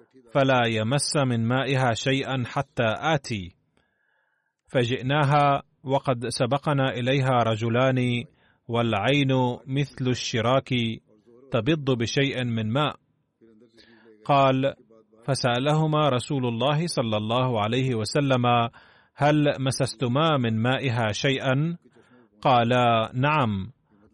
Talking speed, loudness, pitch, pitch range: 85 wpm, -24 LUFS, 130 Hz, 115-140 Hz